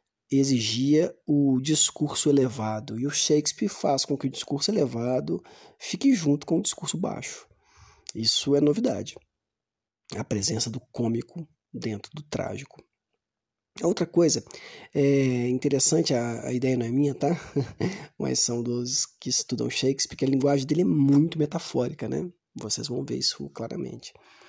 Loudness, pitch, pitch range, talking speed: -25 LUFS, 135 Hz, 120-150 Hz, 145 wpm